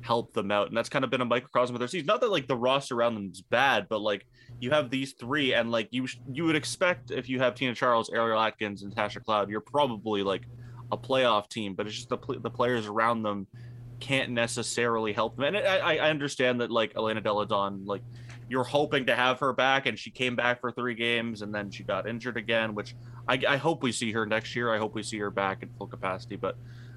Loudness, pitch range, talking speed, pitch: -28 LUFS, 110-130 Hz, 245 wpm, 120 Hz